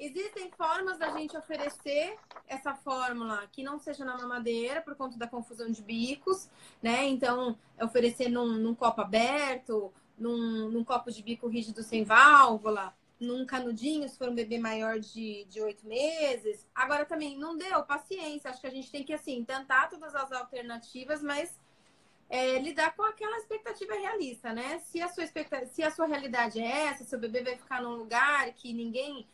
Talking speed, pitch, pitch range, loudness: 175 wpm, 260 Hz, 235-305 Hz, -31 LUFS